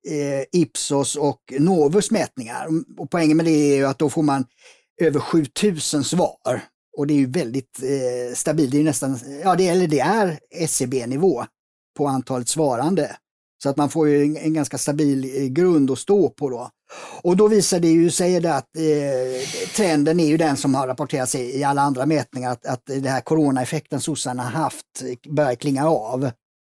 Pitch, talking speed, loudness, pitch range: 145 Hz, 175 wpm, -20 LUFS, 135-160 Hz